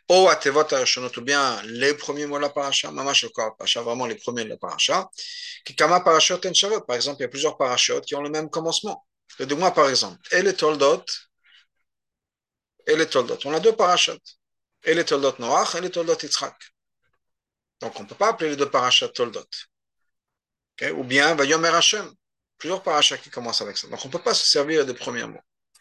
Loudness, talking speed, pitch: -21 LUFS, 215 wpm, 165 Hz